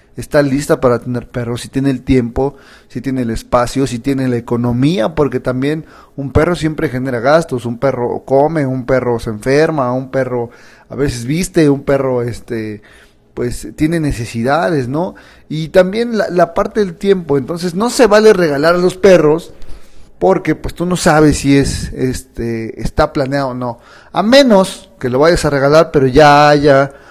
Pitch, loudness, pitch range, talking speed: 140 Hz, -13 LUFS, 125-160 Hz, 175 wpm